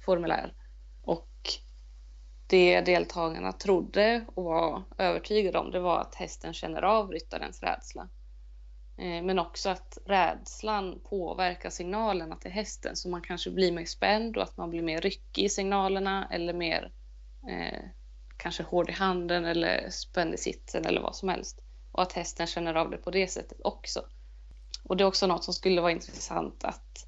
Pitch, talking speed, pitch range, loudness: 175 Hz, 165 wpm, 160-190 Hz, -30 LUFS